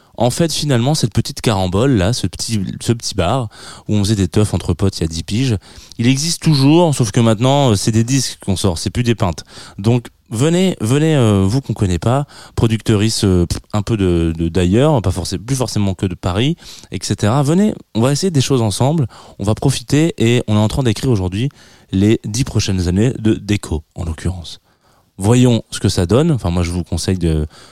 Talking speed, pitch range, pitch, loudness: 210 wpm, 95-130 Hz, 110 Hz, -16 LUFS